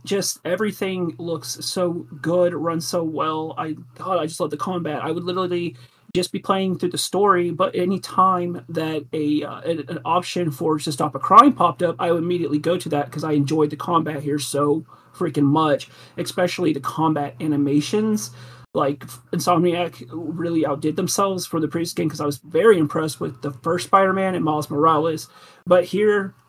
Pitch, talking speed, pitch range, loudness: 165 Hz, 180 wpm, 150-180 Hz, -21 LUFS